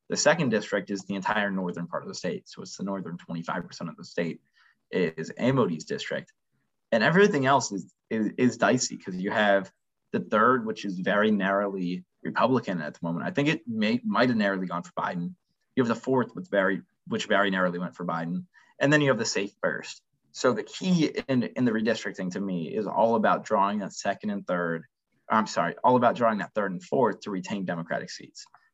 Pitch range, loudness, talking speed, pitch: 90-130 Hz, -27 LUFS, 210 wpm, 100 Hz